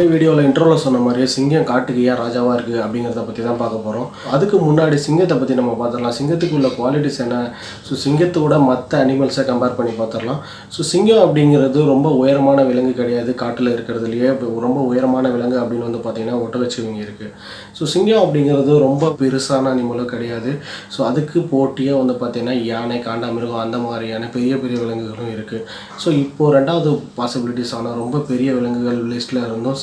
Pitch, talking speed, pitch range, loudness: 125 Hz, 165 wpm, 120-140 Hz, -17 LUFS